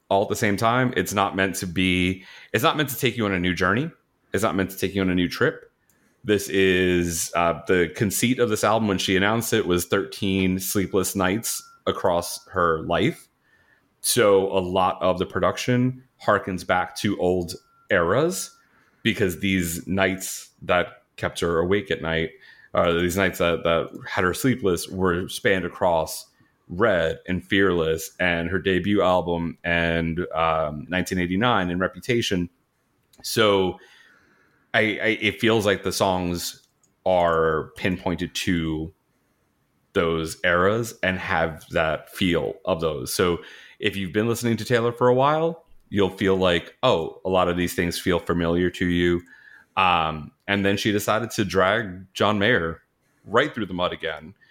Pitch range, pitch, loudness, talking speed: 85-105 Hz, 95 Hz, -23 LUFS, 165 wpm